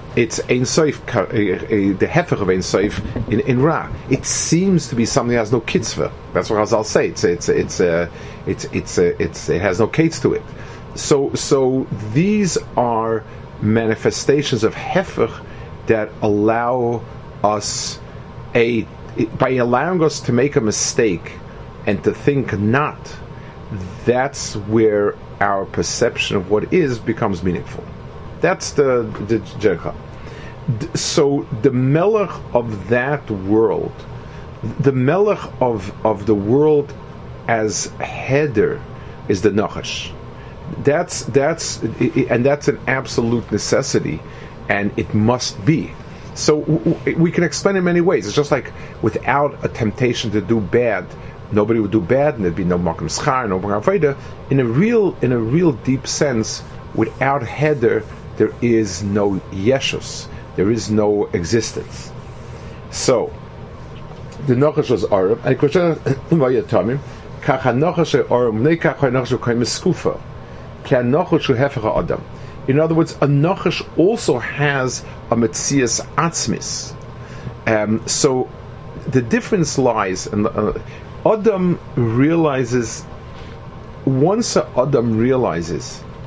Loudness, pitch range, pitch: -18 LUFS, 110-145 Hz, 125 Hz